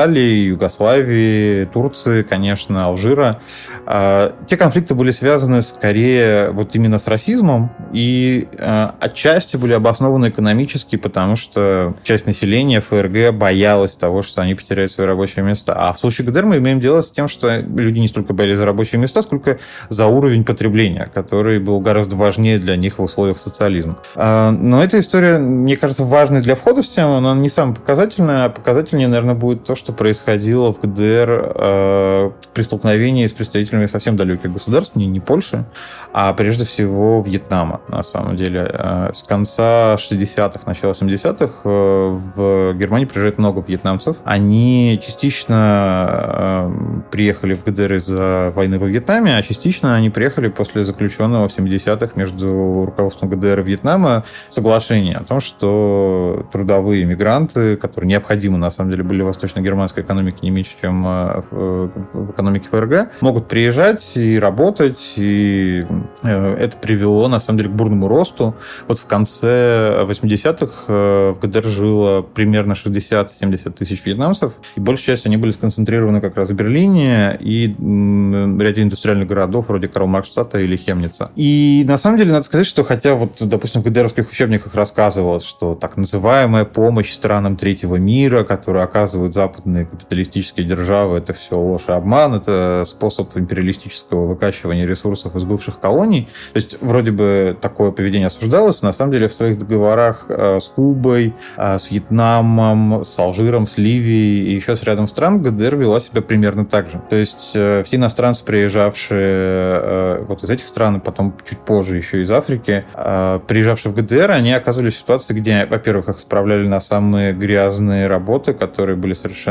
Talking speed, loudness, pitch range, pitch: 155 wpm, -15 LUFS, 95-120 Hz, 105 Hz